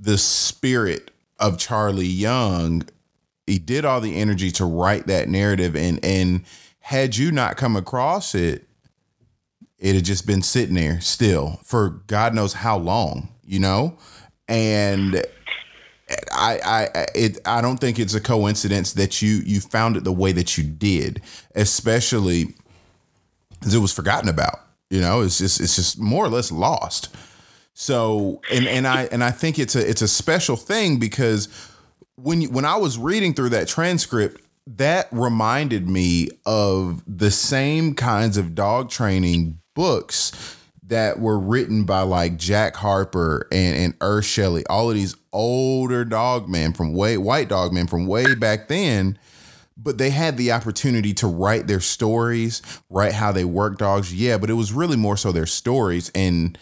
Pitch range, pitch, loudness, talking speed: 95-120 Hz, 105 Hz, -20 LUFS, 165 wpm